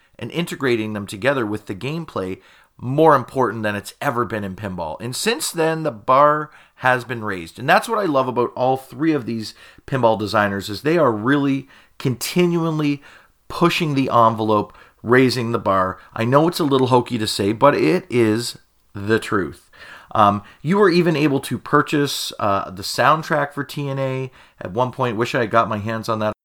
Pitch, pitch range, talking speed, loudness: 125 Hz, 110-145 Hz, 185 wpm, -19 LUFS